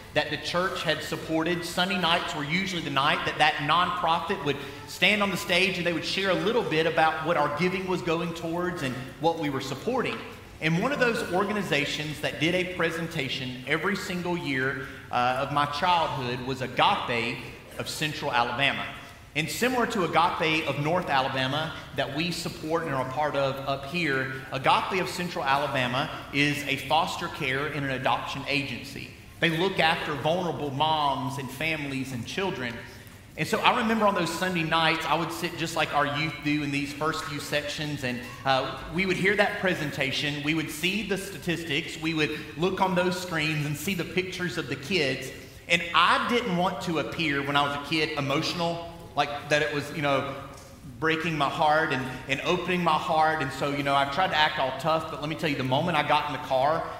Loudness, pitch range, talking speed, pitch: -26 LUFS, 140-170 Hz, 200 wpm, 155 Hz